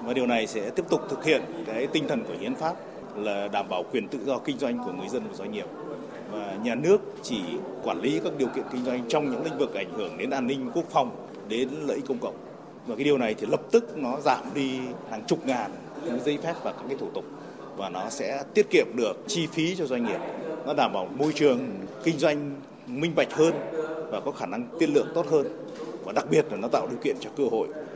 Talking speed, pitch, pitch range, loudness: 250 wpm, 150 Hz, 125-165 Hz, -28 LUFS